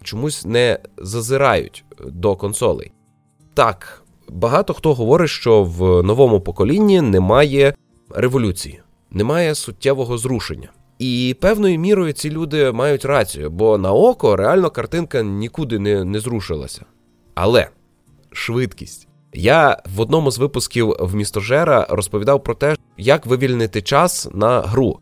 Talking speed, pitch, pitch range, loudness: 120 wpm, 125 Hz, 105-145 Hz, -17 LUFS